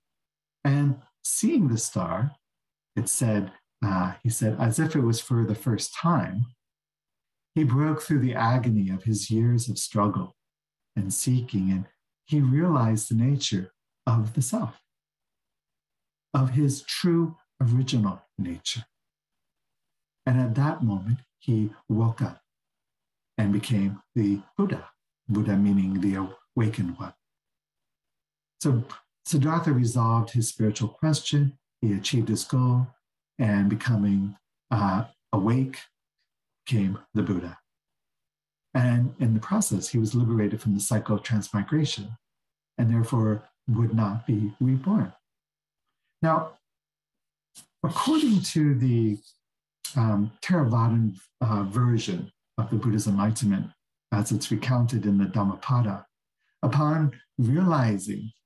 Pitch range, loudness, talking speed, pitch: 105-135 Hz, -26 LUFS, 115 wpm, 115 Hz